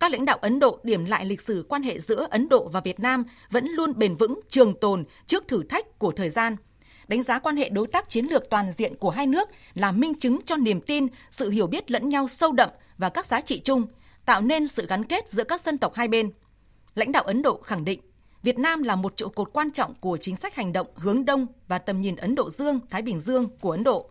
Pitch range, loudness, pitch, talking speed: 205-275 Hz, -25 LUFS, 240 Hz, 260 wpm